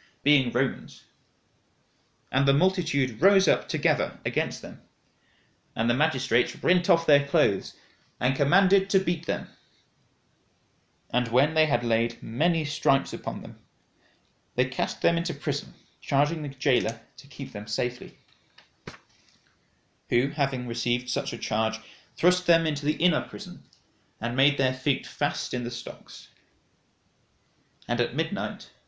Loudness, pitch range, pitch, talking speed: -26 LUFS, 125-165 Hz, 140 Hz, 135 wpm